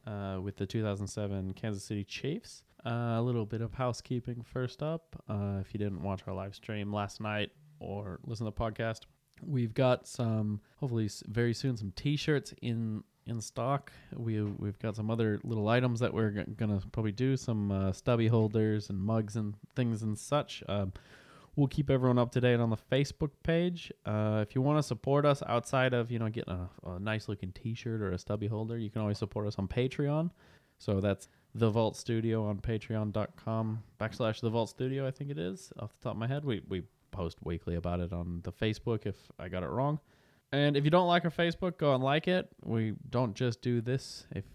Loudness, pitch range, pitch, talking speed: -34 LUFS, 105-130 Hz, 115 Hz, 210 wpm